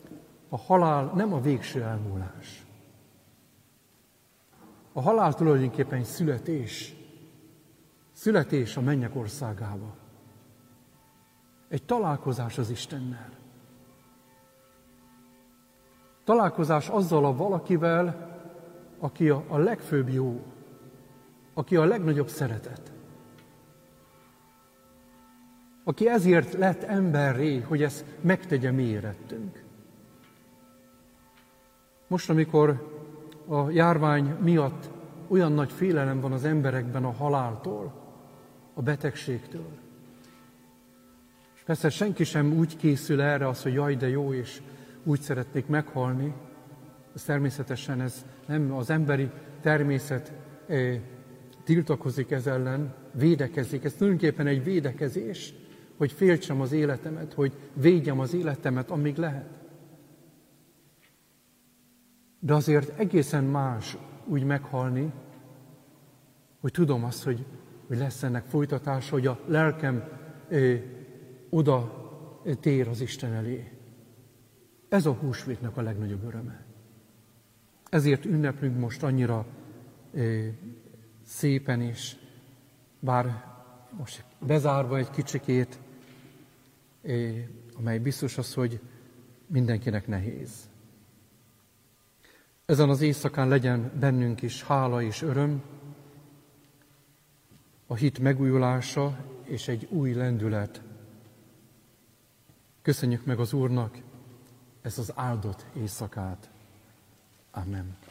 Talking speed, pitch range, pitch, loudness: 95 wpm, 125-150 Hz, 135 Hz, -27 LUFS